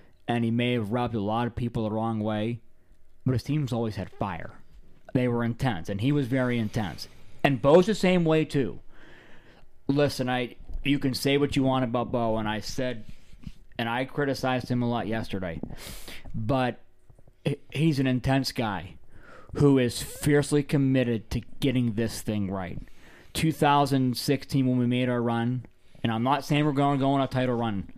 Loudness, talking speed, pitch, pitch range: -27 LUFS, 180 wpm, 125 Hz, 110-135 Hz